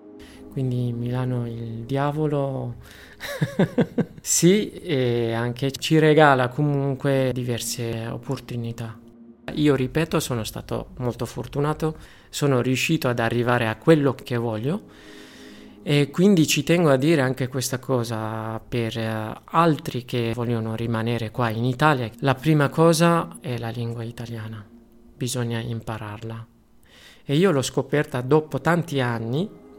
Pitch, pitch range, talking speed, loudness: 125 Hz, 115-150 Hz, 120 wpm, -23 LUFS